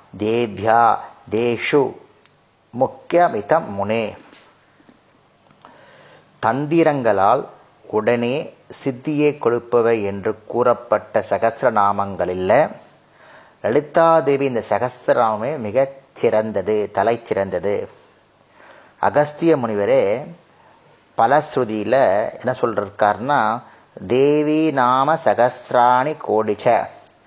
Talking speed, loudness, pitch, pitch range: 55 wpm, -19 LUFS, 120 Hz, 110-150 Hz